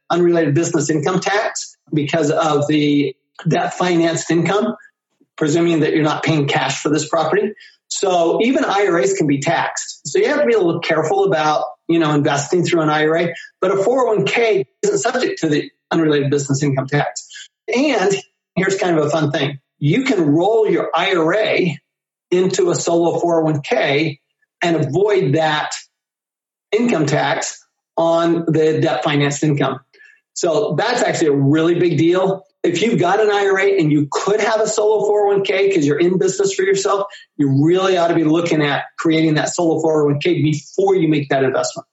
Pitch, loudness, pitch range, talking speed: 165 Hz, -17 LUFS, 150-195 Hz, 170 wpm